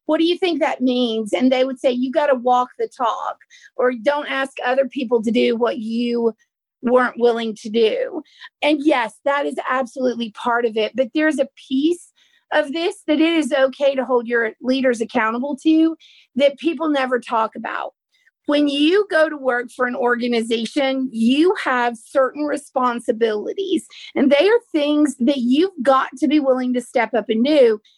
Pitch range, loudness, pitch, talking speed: 245-300 Hz, -19 LUFS, 265 Hz, 180 wpm